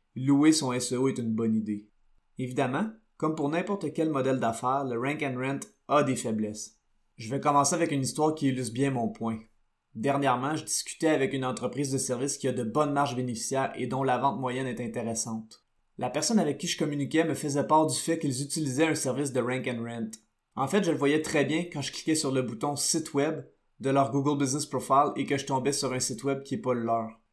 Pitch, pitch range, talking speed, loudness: 135 Hz, 125-145 Hz, 230 wpm, -28 LUFS